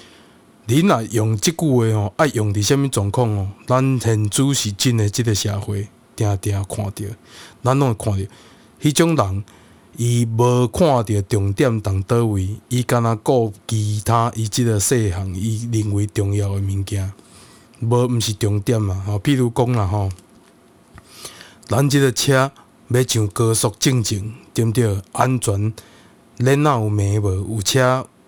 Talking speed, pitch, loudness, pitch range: 215 characters per minute, 115 Hz, -19 LUFS, 105-125 Hz